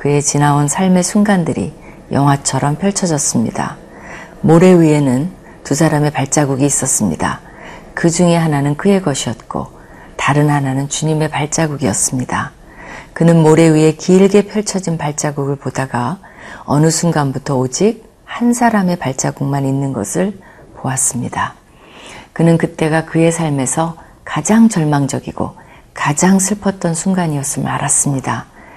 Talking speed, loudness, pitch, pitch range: 300 characters per minute, -14 LUFS, 155 Hz, 140-180 Hz